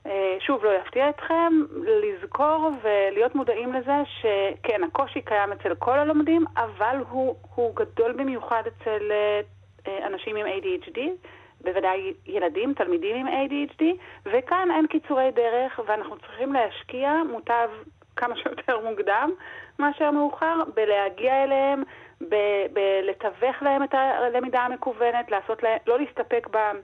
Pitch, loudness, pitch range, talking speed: 255 Hz, -25 LUFS, 215-300 Hz, 120 wpm